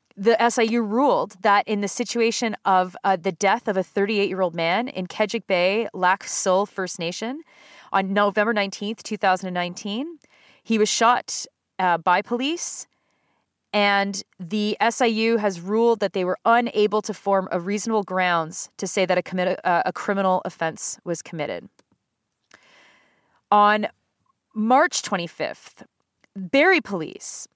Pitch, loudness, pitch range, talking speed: 205 Hz, -22 LUFS, 185-230 Hz, 140 wpm